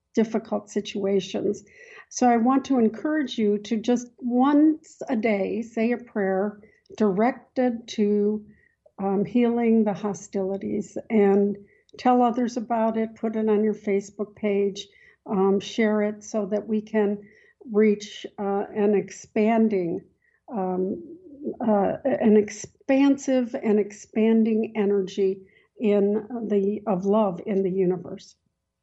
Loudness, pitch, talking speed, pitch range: -24 LUFS, 215 Hz, 120 wpm, 200-235 Hz